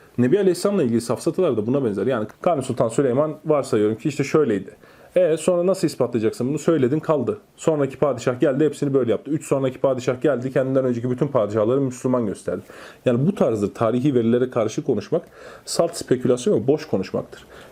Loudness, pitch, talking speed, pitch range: -21 LUFS, 140 Hz, 170 wpm, 125-155 Hz